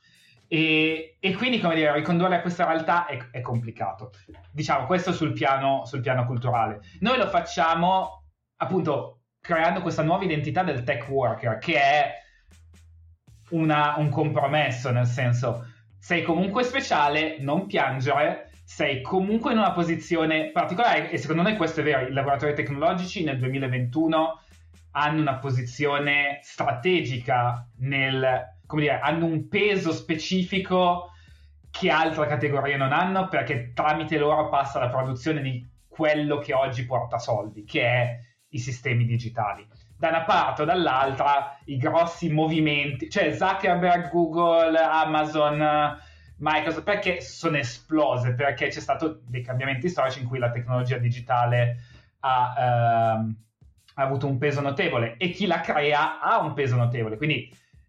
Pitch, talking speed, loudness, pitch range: 145 Hz, 140 wpm, -24 LUFS, 125-160 Hz